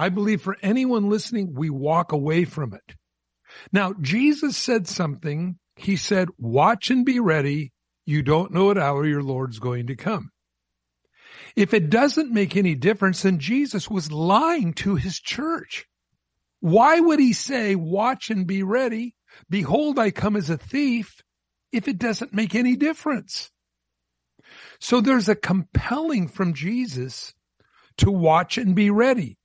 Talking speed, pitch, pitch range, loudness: 150 wpm, 195 Hz, 155-235 Hz, -22 LUFS